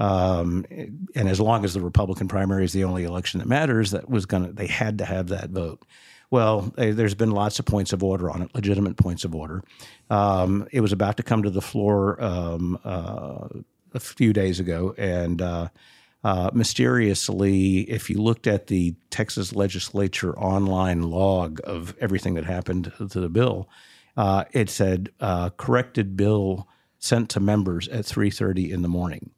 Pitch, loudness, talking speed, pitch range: 95 Hz, -24 LUFS, 175 wpm, 90-105 Hz